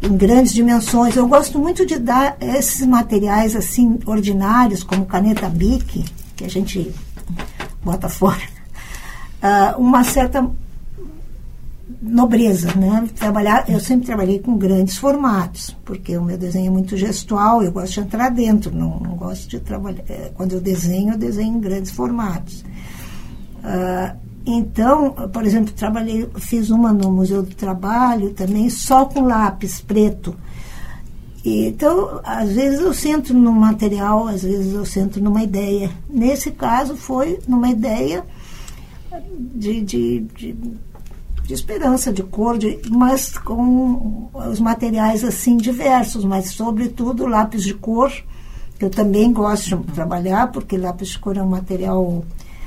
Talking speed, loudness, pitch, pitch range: 140 wpm, -17 LUFS, 215 Hz, 190-245 Hz